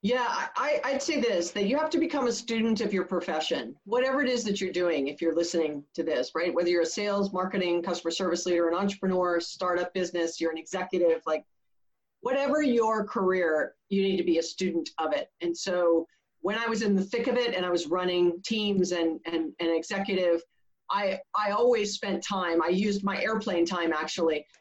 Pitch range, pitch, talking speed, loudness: 170-205 Hz, 185 Hz, 205 wpm, -28 LUFS